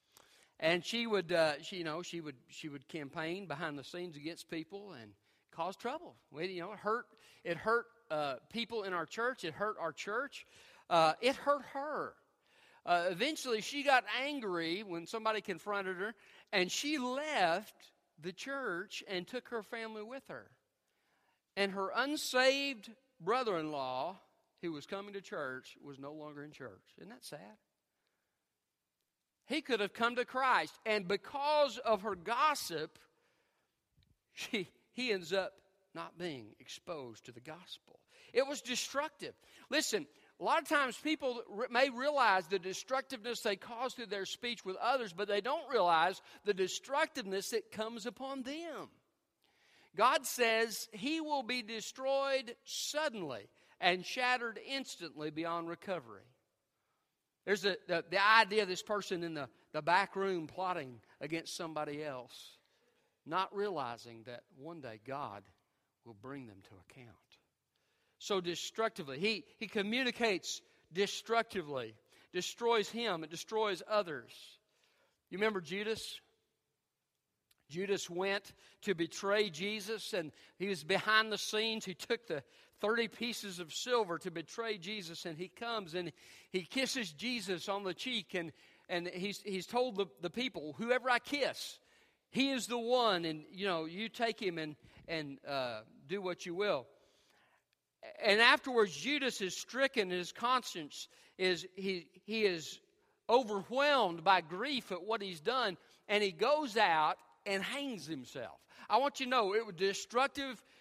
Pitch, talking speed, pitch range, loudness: 205 Hz, 150 wpm, 175-245 Hz, -36 LUFS